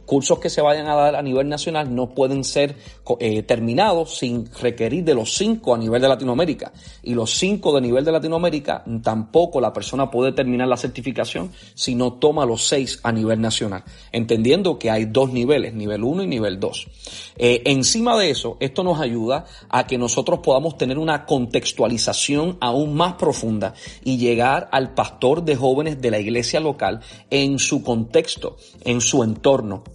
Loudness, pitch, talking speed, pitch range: -20 LUFS, 130 Hz, 175 wpm, 115-150 Hz